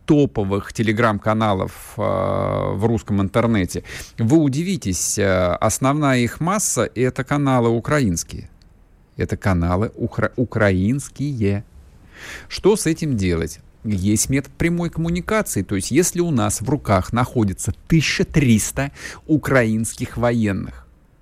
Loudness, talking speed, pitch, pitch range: -20 LUFS, 105 wpm, 115 Hz, 100-140 Hz